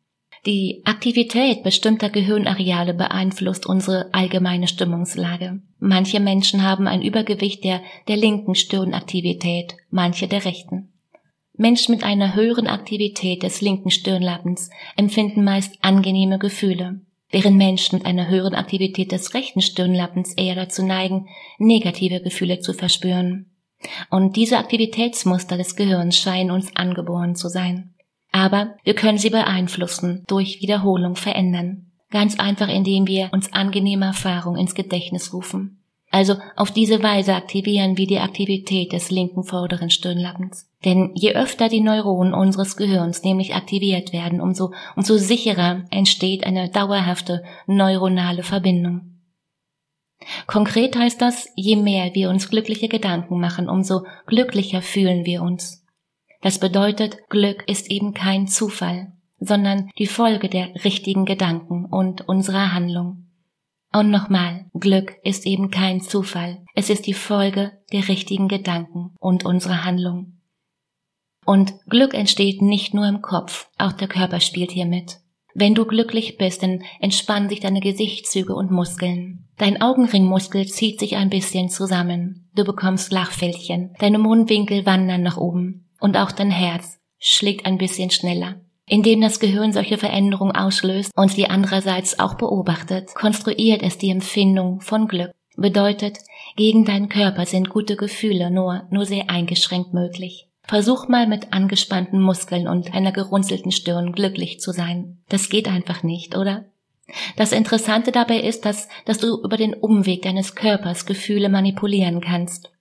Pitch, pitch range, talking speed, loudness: 190 Hz, 180-205 Hz, 140 wpm, -19 LUFS